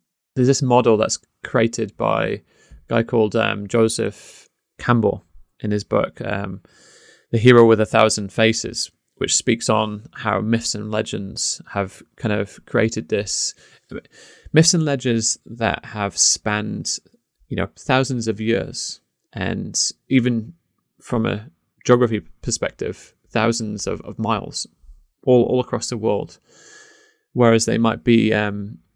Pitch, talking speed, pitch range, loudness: 115 Hz, 135 wpm, 105-125 Hz, -20 LUFS